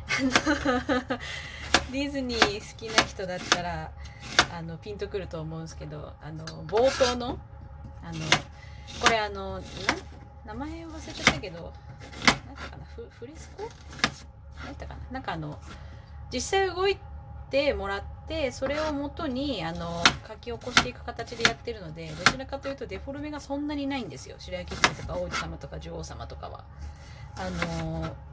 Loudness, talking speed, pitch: -28 LUFS, 300 characters per minute, 185 Hz